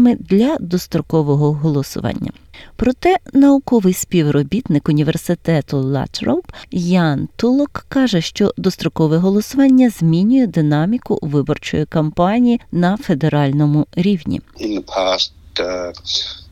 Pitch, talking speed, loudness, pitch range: 175 Hz, 75 wpm, -16 LUFS, 150-230 Hz